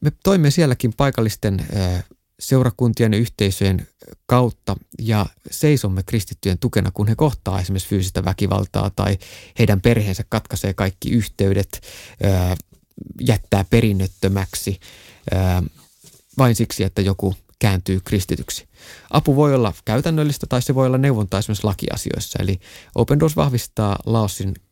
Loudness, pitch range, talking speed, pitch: -20 LUFS, 95-120 Hz, 115 wpm, 105 Hz